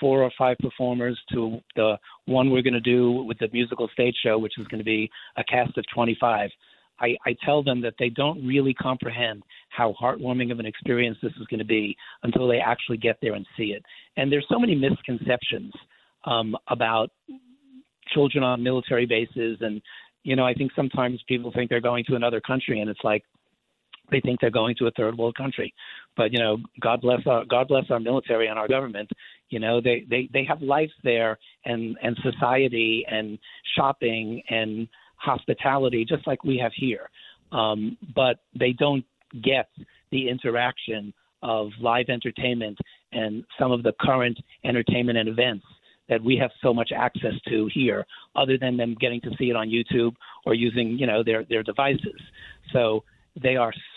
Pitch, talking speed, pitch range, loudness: 120 Hz, 185 wpm, 115-130 Hz, -25 LUFS